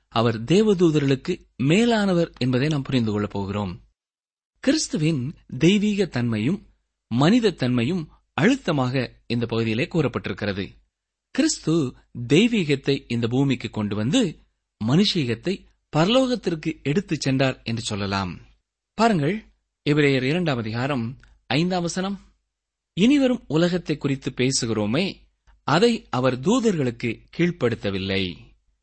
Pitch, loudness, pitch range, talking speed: 135 Hz, -23 LUFS, 115-175 Hz, 90 wpm